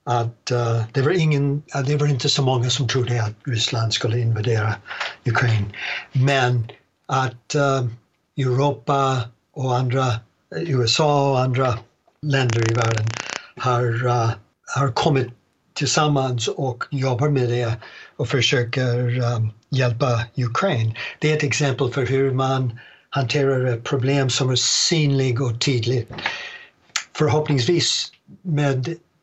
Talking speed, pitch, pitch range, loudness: 125 wpm, 130 Hz, 120-140 Hz, -21 LUFS